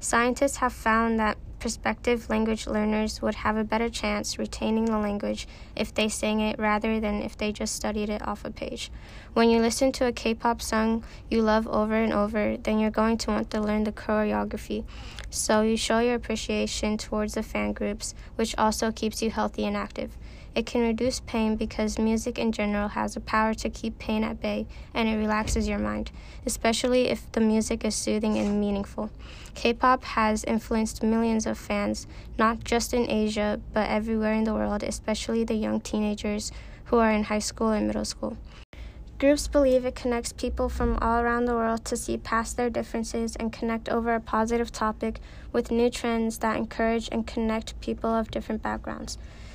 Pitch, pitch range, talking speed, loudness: 220 Hz, 210-230 Hz, 190 wpm, -27 LUFS